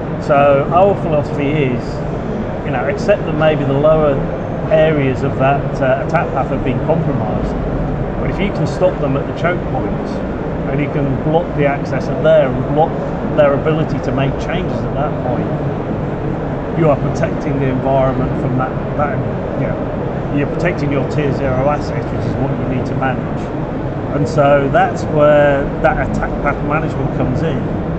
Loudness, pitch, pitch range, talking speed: -16 LUFS, 145 Hz, 135-155 Hz, 175 wpm